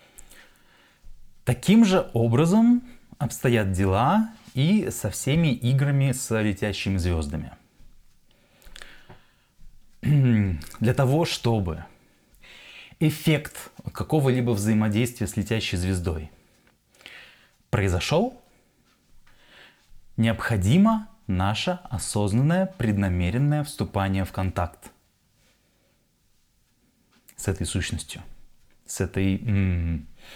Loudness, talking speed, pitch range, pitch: -24 LUFS, 65 wpm, 95-145 Hz, 115 Hz